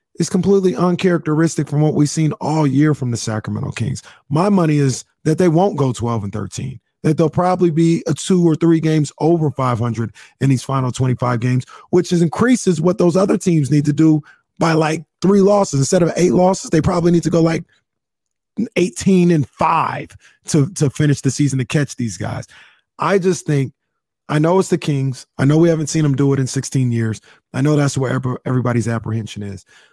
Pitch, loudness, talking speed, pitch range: 150 Hz, -17 LUFS, 205 wpm, 130-170 Hz